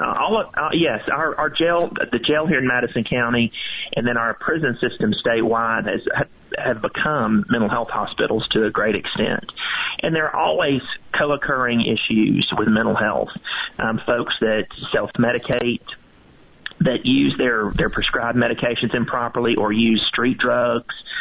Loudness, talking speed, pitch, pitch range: -20 LUFS, 155 wpm, 120 Hz, 115-135 Hz